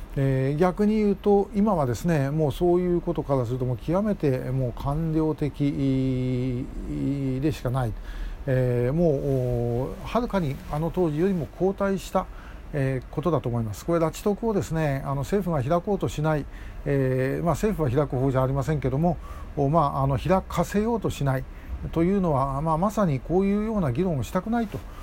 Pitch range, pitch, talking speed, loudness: 130-180 Hz, 150 Hz, 330 characters per minute, -25 LUFS